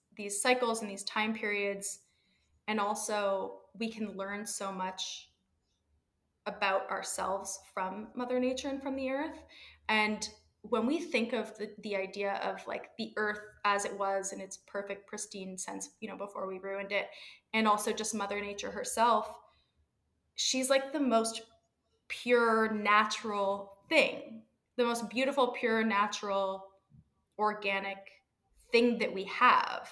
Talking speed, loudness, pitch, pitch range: 140 wpm, -32 LUFS, 210 Hz, 195-230 Hz